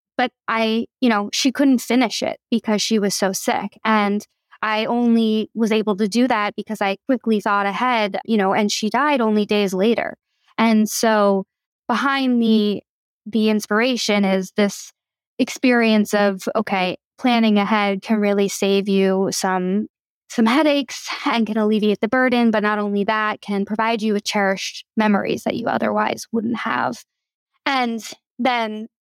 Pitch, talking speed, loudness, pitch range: 220 Hz, 155 wpm, -19 LUFS, 205-240 Hz